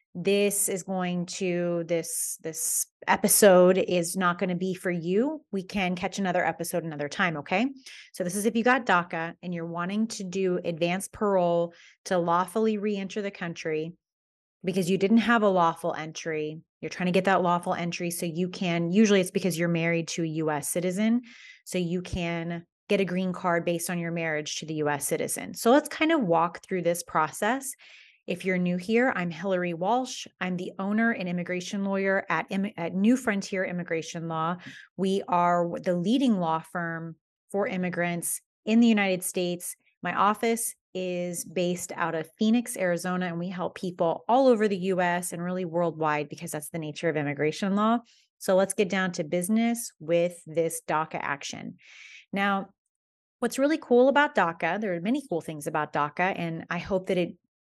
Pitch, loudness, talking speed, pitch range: 180 Hz, -27 LUFS, 180 wpm, 170-200 Hz